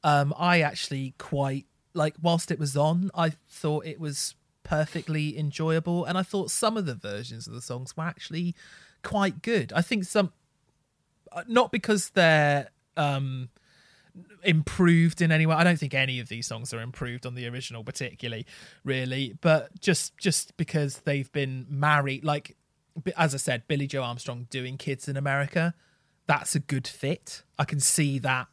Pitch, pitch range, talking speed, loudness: 150 Hz, 135-170 Hz, 170 wpm, -27 LUFS